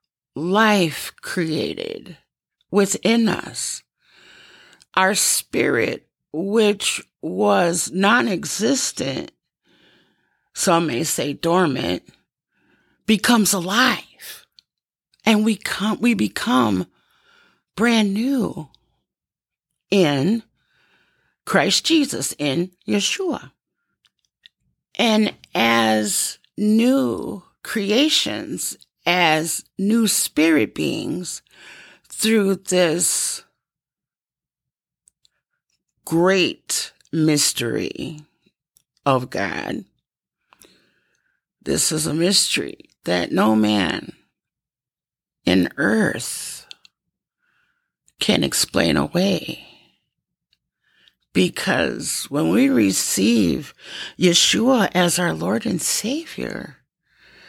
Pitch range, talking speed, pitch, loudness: 165-235 Hz, 65 wpm, 200 Hz, -19 LUFS